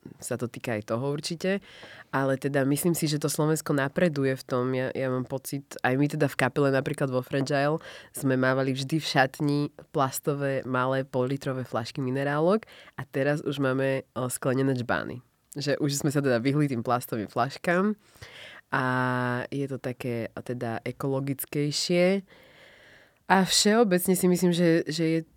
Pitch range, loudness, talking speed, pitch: 130-155 Hz, -27 LUFS, 160 wpm, 135 Hz